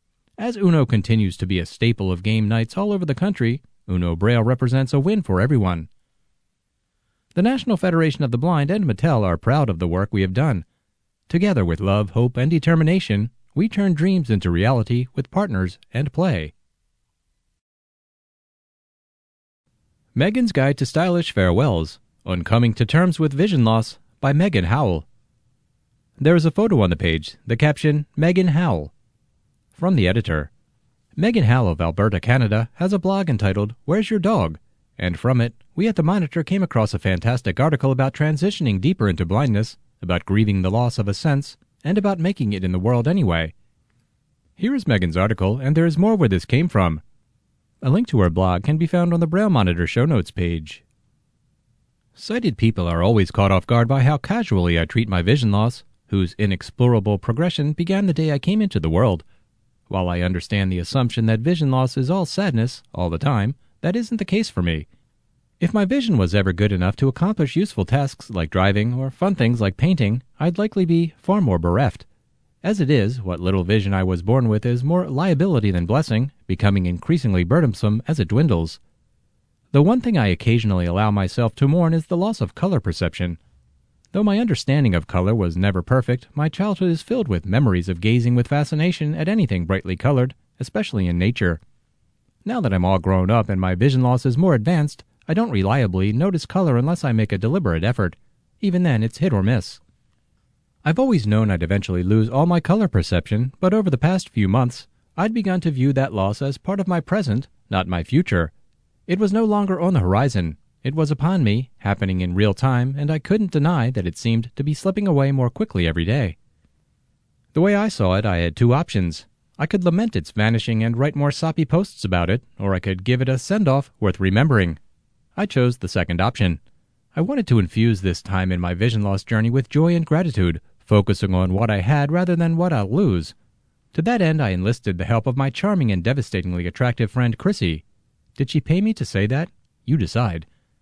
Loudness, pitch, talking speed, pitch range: -20 LUFS, 120 Hz, 195 wpm, 95-165 Hz